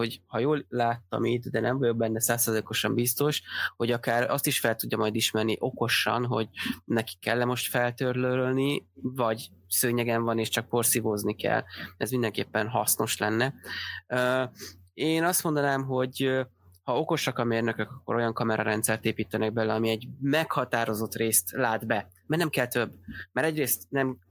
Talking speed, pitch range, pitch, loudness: 155 wpm, 110-130 Hz, 120 Hz, -27 LUFS